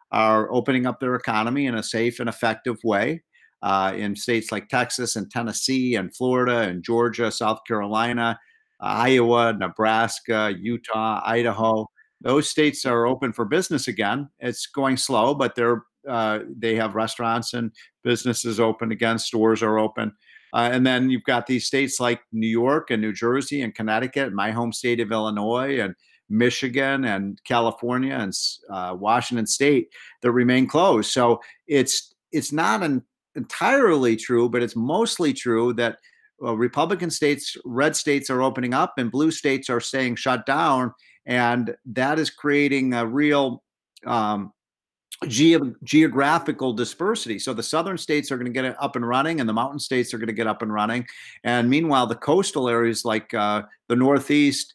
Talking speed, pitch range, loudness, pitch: 165 wpm, 115-130 Hz, -22 LUFS, 120 Hz